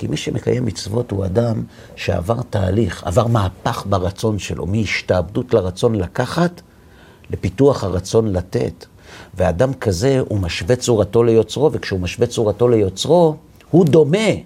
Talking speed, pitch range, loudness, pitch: 125 wpm, 100-125 Hz, -18 LUFS, 115 Hz